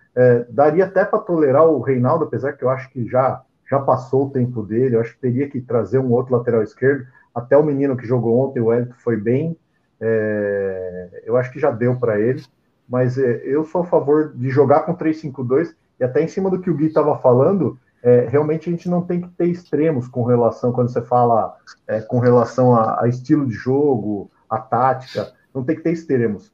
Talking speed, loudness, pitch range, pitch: 215 wpm, -18 LUFS, 120-150 Hz, 130 Hz